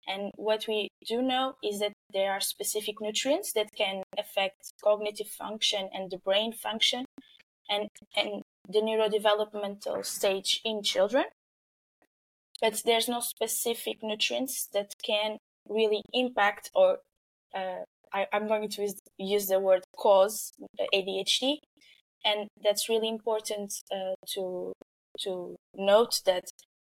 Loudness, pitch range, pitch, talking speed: -29 LUFS, 195-225 Hz, 210 Hz, 125 wpm